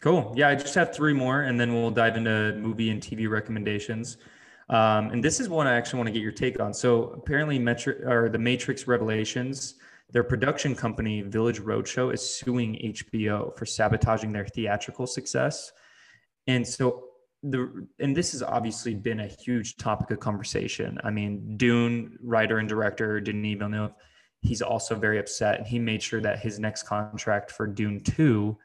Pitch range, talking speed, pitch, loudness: 110-125 Hz, 180 wpm, 115 Hz, -27 LUFS